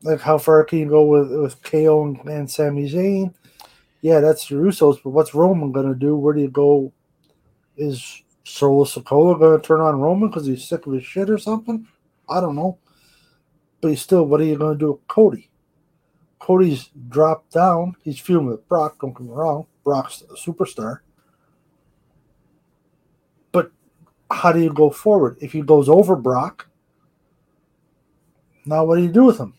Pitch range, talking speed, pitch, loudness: 145-170 Hz, 180 wpm, 155 Hz, -18 LUFS